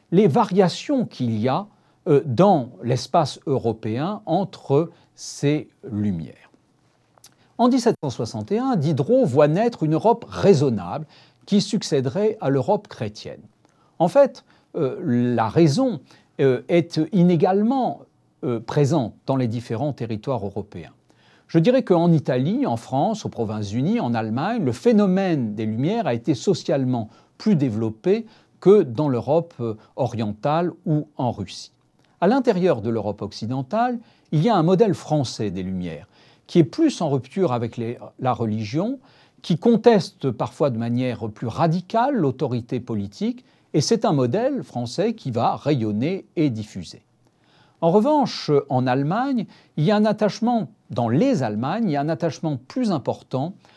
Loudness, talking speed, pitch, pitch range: -22 LUFS, 135 wpm, 150 Hz, 120-195 Hz